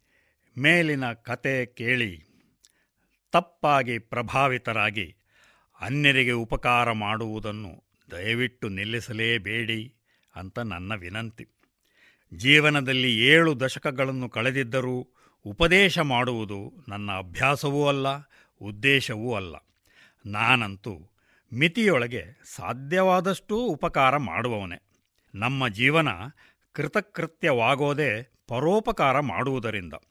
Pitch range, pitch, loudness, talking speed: 110-145 Hz, 125 Hz, -24 LUFS, 70 wpm